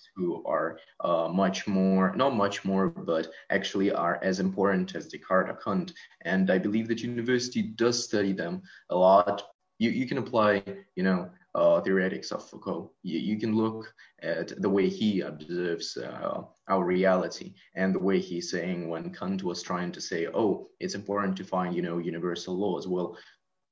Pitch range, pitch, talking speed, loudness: 90-105 Hz, 95 Hz, 175 wpm, -28 LUFS